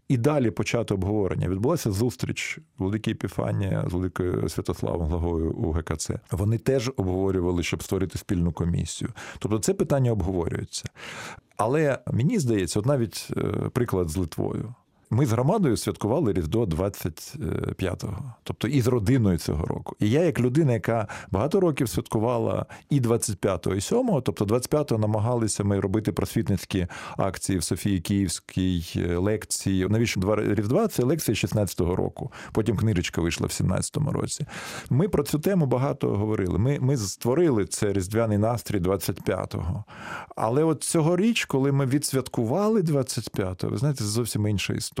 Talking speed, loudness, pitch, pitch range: 145 wpm, -26 LUFS, 110 Hz, 95-135 Hz